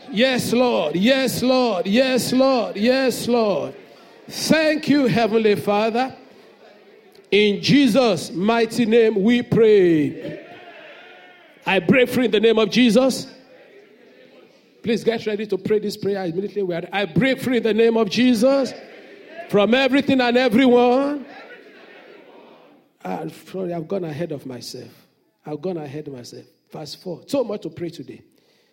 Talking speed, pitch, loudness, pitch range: 130 wpm, 230 Hz, -19 LUFS, 195-255 Hz